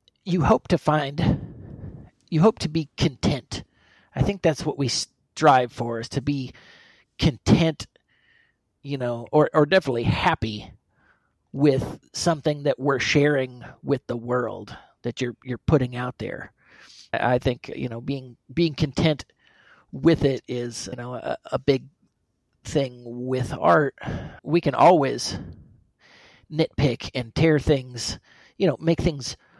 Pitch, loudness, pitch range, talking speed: 135 Hz, -24 LUFS, 120-155 Hz, 140 wpm